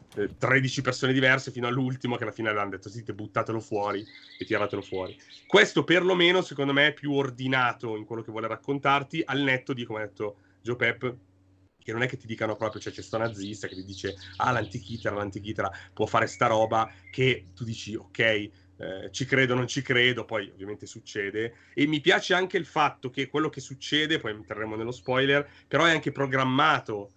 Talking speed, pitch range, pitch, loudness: 195 wpm, 105-135 Hz, 120 Hz, -27 LUFS